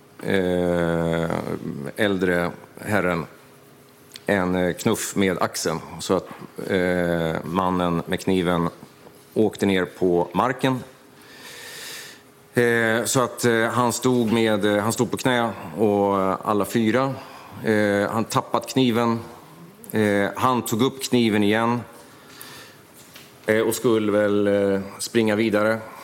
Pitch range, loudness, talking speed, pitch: 95-120 Hz, -22 LUFS, 90 wpm, 105 Hz